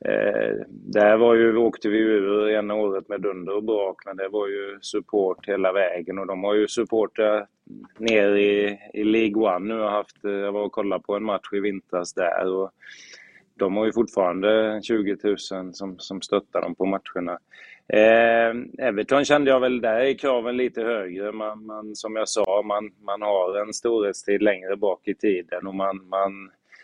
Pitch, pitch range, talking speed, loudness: 105 Hz, 100-110 Hz, 185 wpm, -23 LUFS